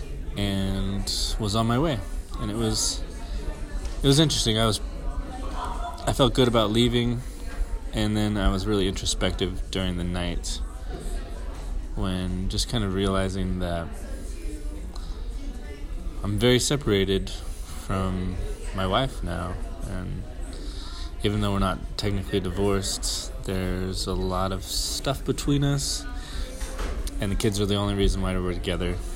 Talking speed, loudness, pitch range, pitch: 130 wpm, -27 LUFS, 80-100 Hz, 95 Hz